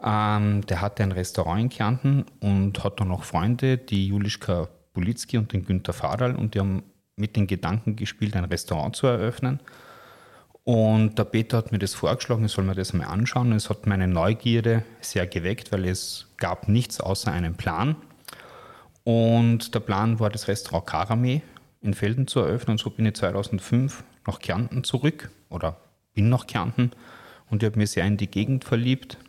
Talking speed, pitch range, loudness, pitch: 180 wpm, 100-120 Hz, -25 LUFS, 110 Hz